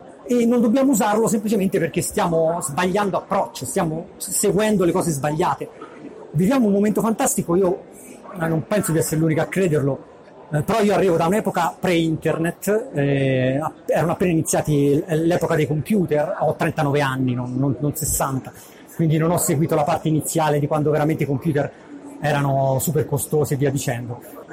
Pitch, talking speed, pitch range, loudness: 160 Hz, 160 wpm, 150-190 Hz, -20 LUFS